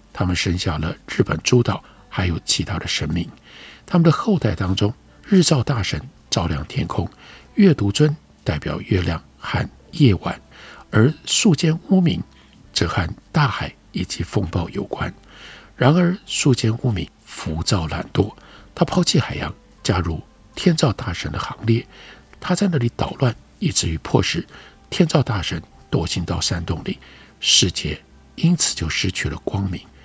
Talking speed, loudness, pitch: 220 characters per minute, -20 LUFS, 130 Hz